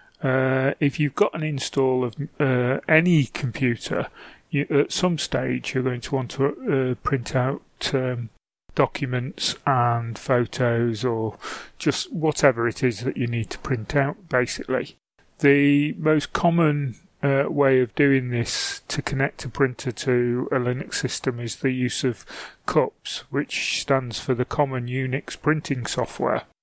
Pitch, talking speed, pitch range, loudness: 130 Hz, 150 wpm, 125-145 Hz, -23 LUFS